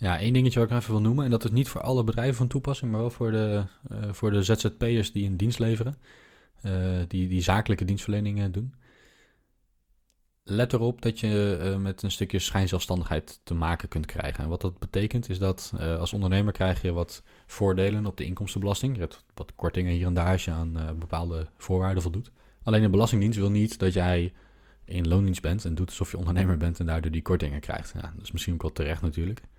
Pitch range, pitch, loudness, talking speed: 90-110 Hz, 95 Hz, -28 LUFS, 220 wpm